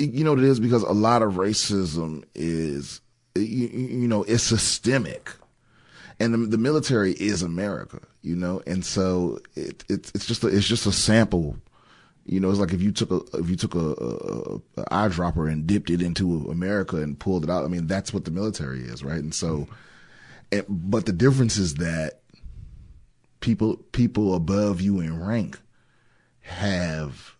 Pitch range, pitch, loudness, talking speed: 85-115 Hz, 95 Hz, -24 LUFS, 180 wpm